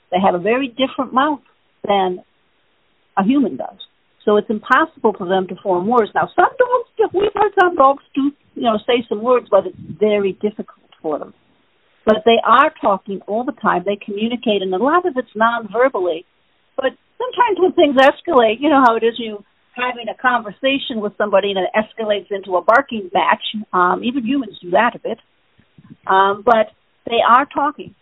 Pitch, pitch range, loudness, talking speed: 230 Hz, 205-270 Hz, -17 LUFS, 180 wpm